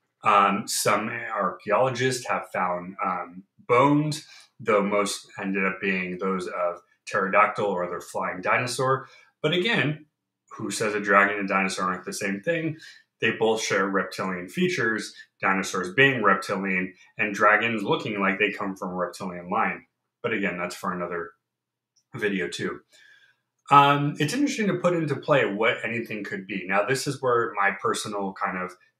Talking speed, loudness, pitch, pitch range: 155 wpm, -24 LUFS, 105 Hz, 95-135 Hz